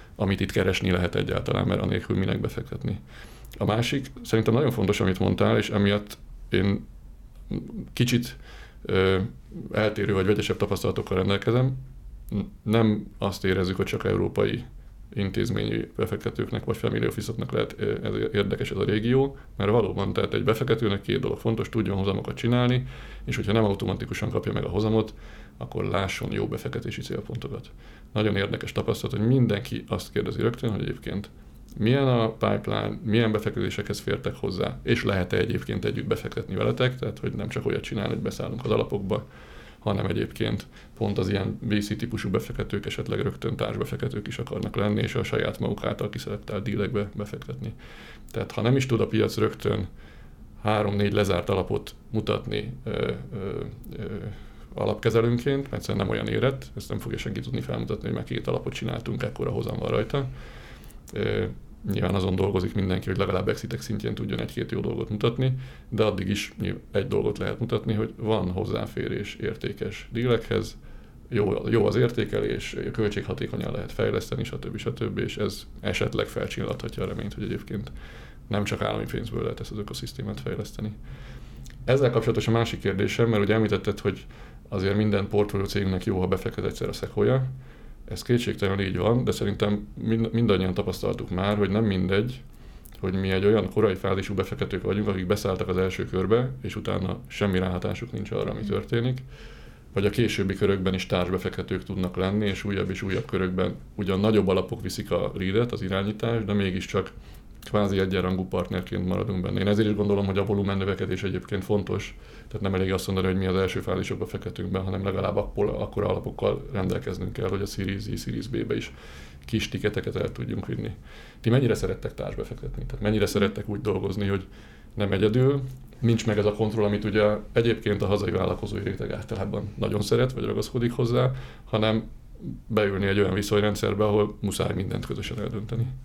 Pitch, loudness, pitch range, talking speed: 105 Hz, -27 LUFS, 95-115 Hz, 165 wpm